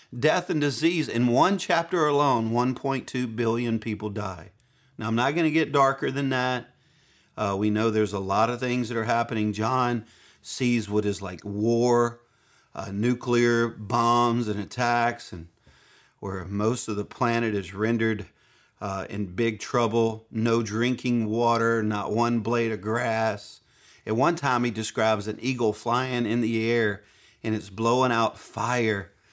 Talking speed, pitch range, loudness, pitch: 160 wpm, 105-120 Hz, -25 LUFS, 115 Hz